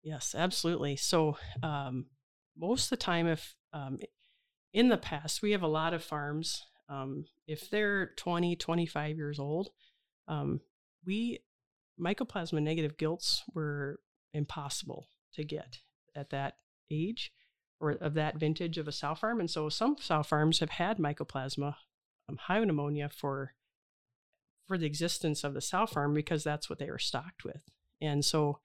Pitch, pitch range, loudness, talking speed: 155 Hz, 145-175 Hz, -34 LUFS, 155 wpm